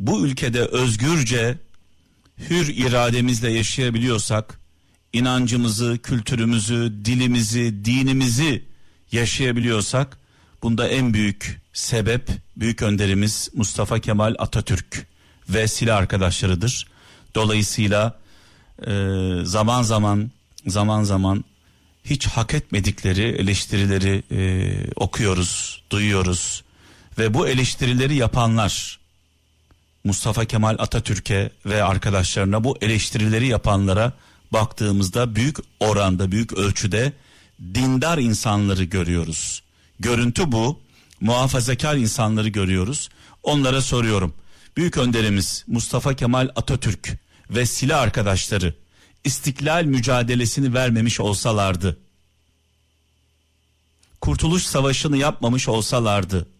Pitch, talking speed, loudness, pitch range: 110 Hz, 80 wpm, -21 LUFS, 95-125 Hz